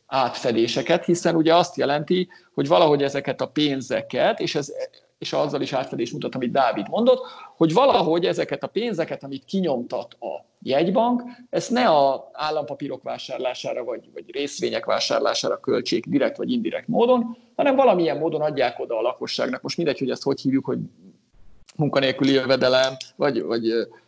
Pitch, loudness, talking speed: 150 Hz, -22 LUFS, 150 wpm